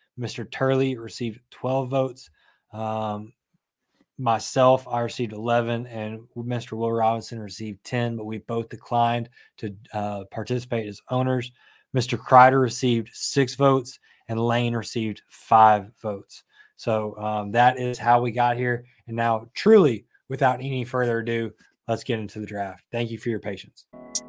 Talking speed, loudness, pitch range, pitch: 150 wpm, -24 LUFS, 110-125 Hz, 120 Hz